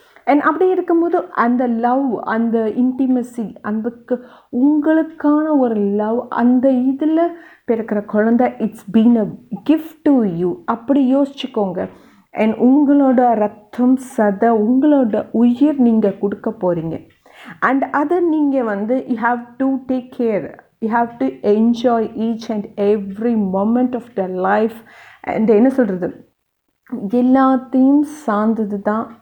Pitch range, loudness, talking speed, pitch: 220-270 Hz, -17 LUFS, 120 wpm, 240 Hz